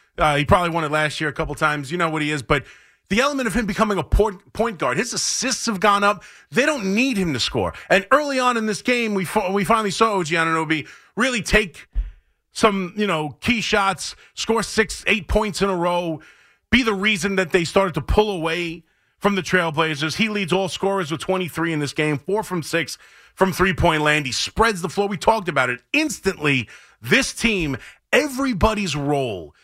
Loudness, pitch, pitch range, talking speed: -20 LUFS, 190 Hz, 160-215 Hz, 210 wpm